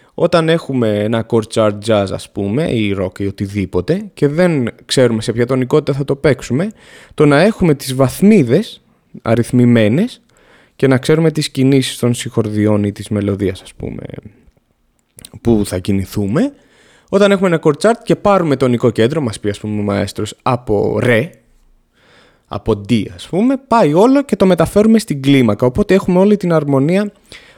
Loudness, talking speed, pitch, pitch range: -14 LUFS, 160 wpm, 130 Hz, 110-170 Hz